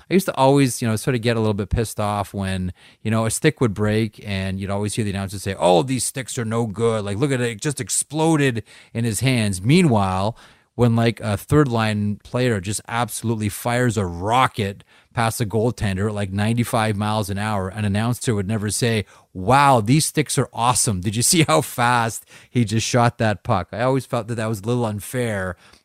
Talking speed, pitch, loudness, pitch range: 220 wpm, 115 Hz, -21 LUFS, 105-125 Hz